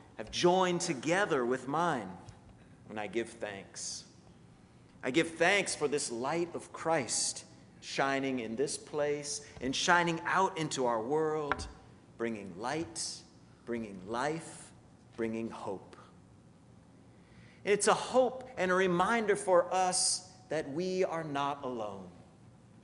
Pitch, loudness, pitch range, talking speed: 150 Hz, -32 LUFS, 120-175 Hz, 120 wpm